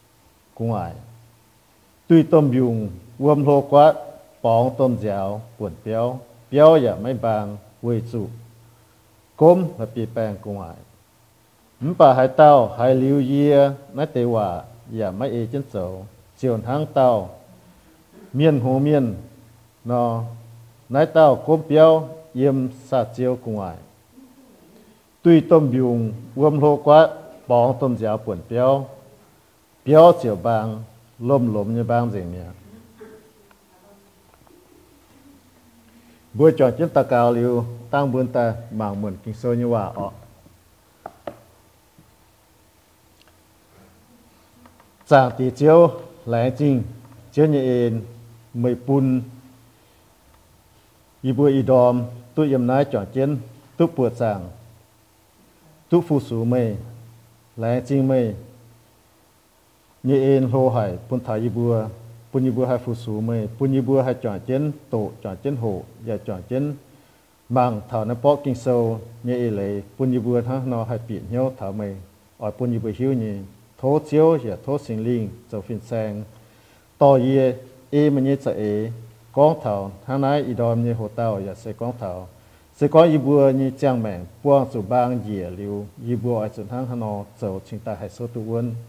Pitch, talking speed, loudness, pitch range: 120 Hz, 140 wpm, -20 LUFS, 110-135 Hz